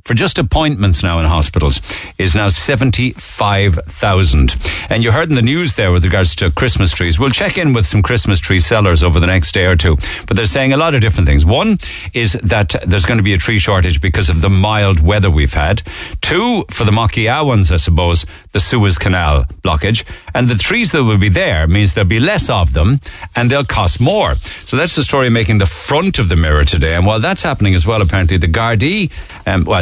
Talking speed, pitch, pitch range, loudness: 220 wpm, 95 Hz, 85-115 Hz, -12 LUFS